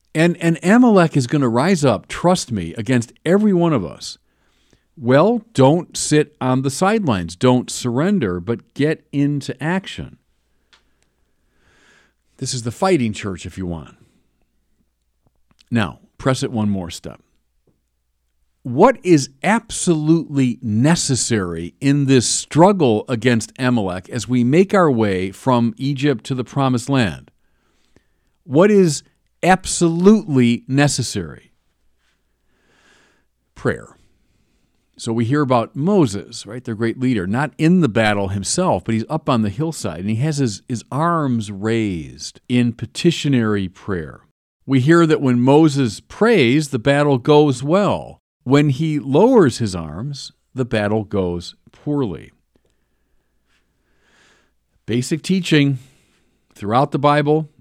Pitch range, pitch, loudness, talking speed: 100-150 Hz, 125 Hz, -17 LUFS, 125 wpm